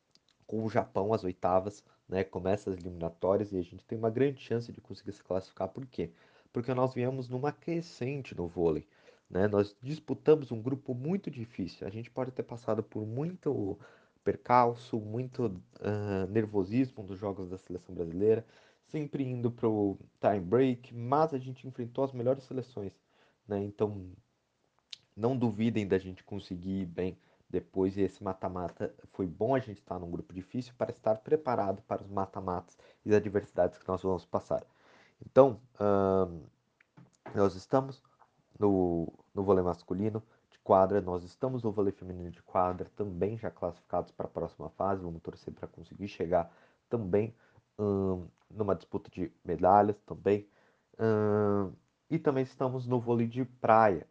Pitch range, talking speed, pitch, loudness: 95-125 Hz, 160 wpm, 105 Hz, -32 LUFS